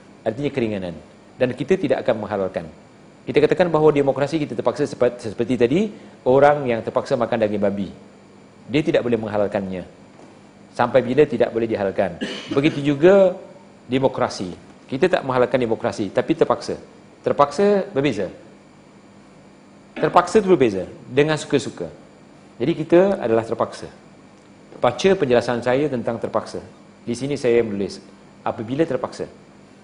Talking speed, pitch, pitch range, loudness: 125 wpm, 125 Hz, 115-155 Hz, -20 LUFS